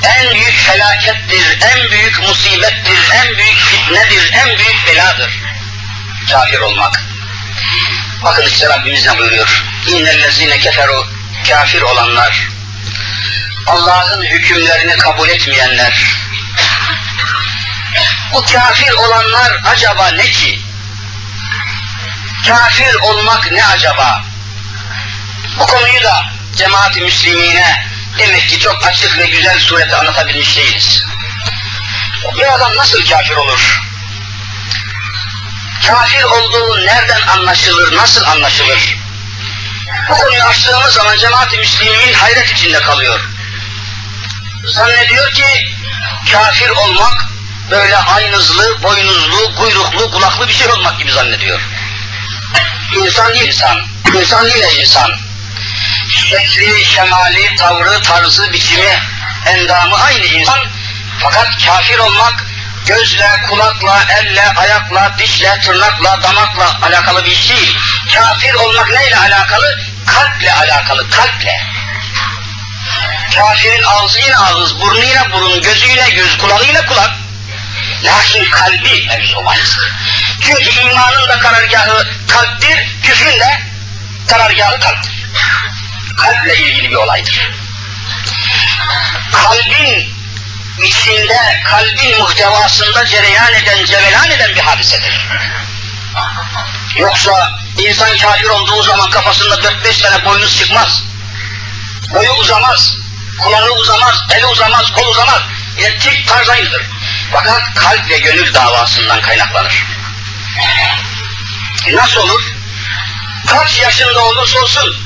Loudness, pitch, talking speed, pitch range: -7 LUFS, 100 Hz, 100 wpm, 100-105 Hz